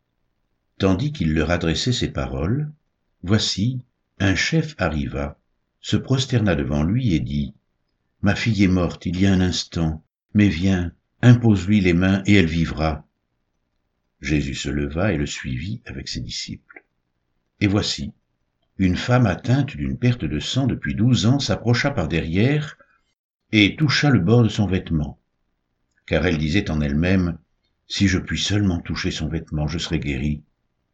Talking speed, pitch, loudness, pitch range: 155 wpm, 85 Hz, -21 LUFS, 70-105 Hz